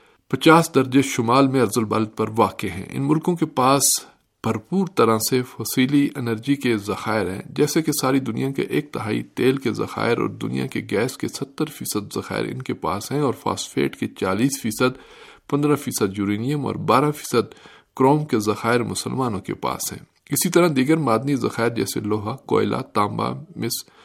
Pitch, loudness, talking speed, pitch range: 130 Hz, -21 LUFS, 175 wpm, 110-145 Hz